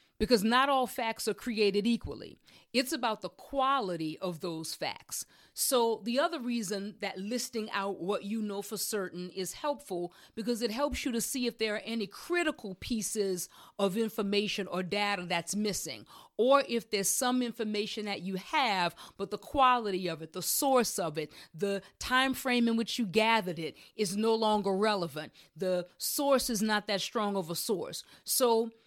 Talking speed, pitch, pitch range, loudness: 175 wpm, 215 Hz, 195-240 Hz, -31 LUFS